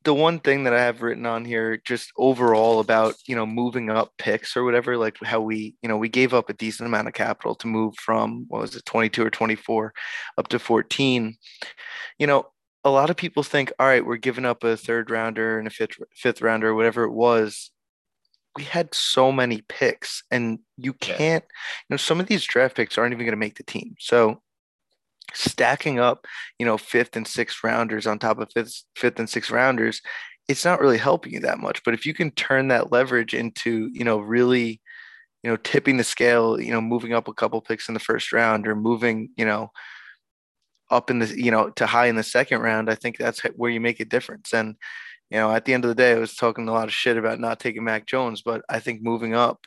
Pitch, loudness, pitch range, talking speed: 115 Hz, -22 LUFS, 110-125 Hz, 230 wpm